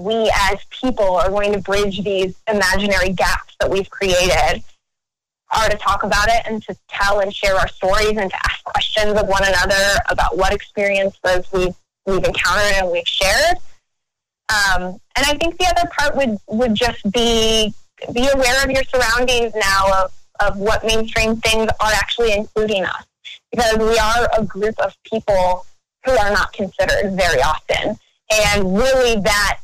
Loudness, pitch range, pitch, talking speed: -17 LUFS, 195-235 Hz, 210 Hz, 170 wpm